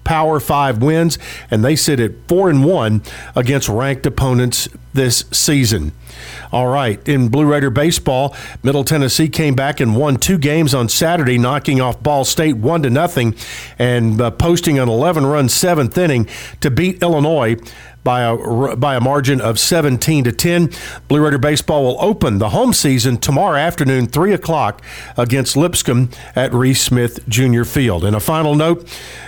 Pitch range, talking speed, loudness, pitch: 120-155 Hz, 165 wpm, -15 LUFS, 135 Hz